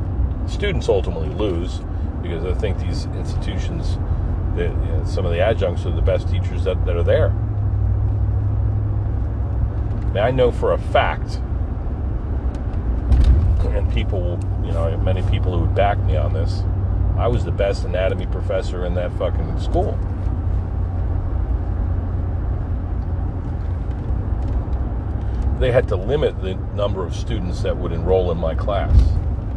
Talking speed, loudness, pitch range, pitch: 130 wpm, -21 LUFS, 90-100 Hz, 95 Hz